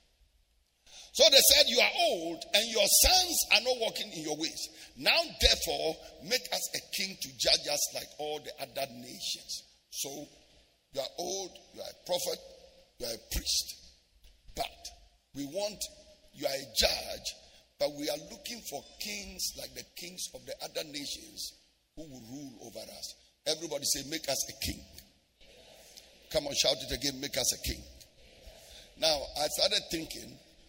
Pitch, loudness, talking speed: 160 Hz, -29 LUFS, 165 wpm